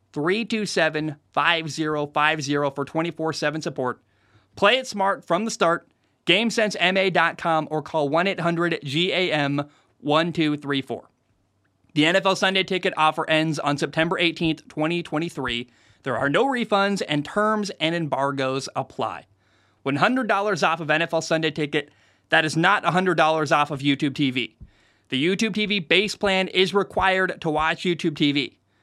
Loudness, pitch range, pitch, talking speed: -22 LUFS, 140-185 Hz, 160 Hz, 120 wpm